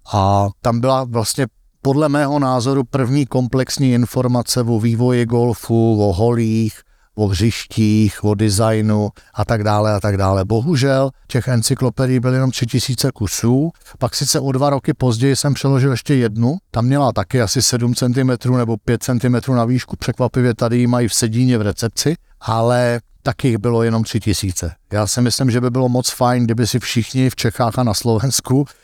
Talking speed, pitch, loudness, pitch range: 175 wpm, 120 Hz, -17 LUFS, 110-130 Hz